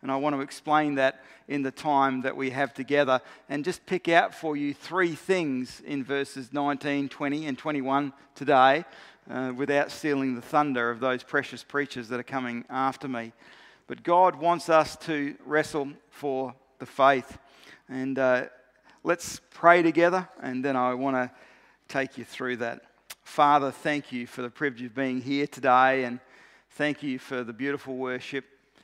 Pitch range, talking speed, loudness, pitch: 130-145 Hz, 170 wpm, -27 LUFS, 135 Hz